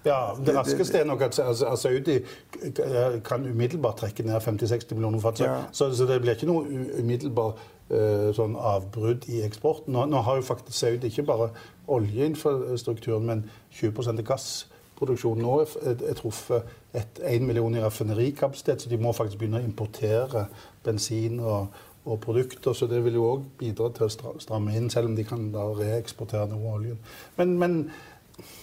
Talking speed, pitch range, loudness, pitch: 155 wpm, 110-130 Hz, -27 LUFS, 115 Hz